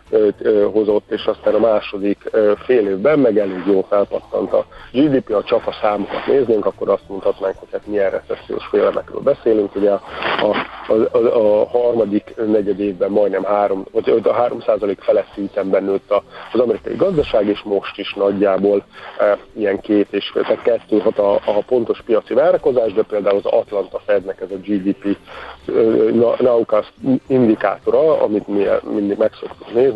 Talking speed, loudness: 150 wpm, -17 LUFS